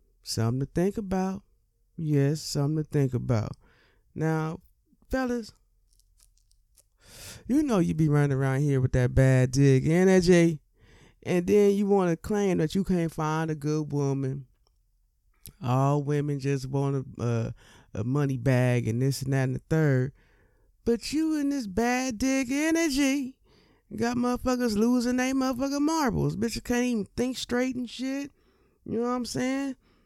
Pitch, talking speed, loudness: 155 Hz, 155 wpm, -26 LUFS